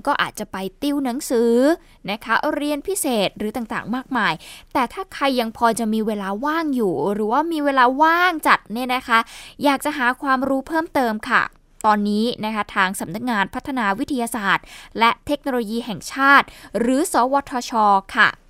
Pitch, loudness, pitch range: 245 Hz, -20 LUFS, 220-280 Hz